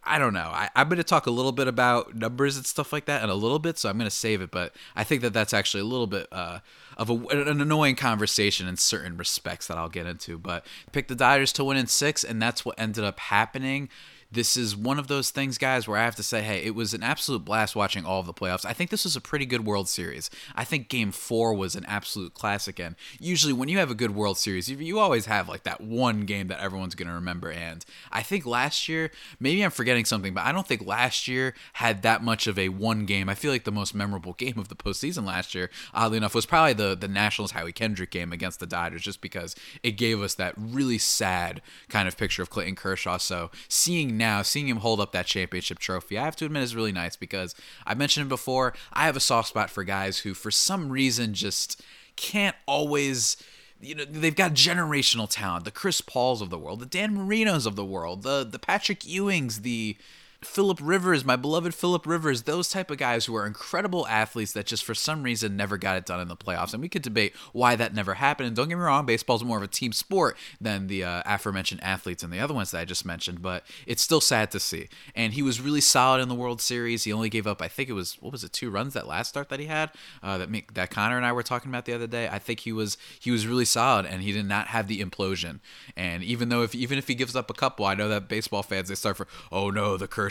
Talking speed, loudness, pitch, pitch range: 255 wpm, -26 LUFS, 115 Hz, 100-135 Hz